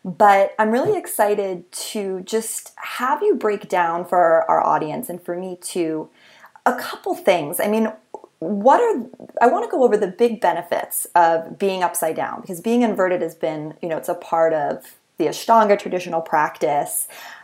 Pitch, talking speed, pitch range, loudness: 195 Hz, 175 wpm, 175-225 Hz, -20 LUFS